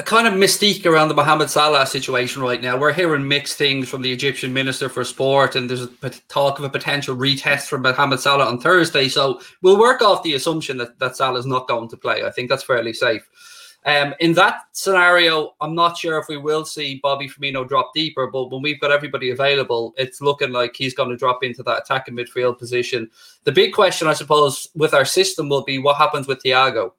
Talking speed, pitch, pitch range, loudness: 220 wpm, 140 Hz, 130-155 Hz, -18 LUFS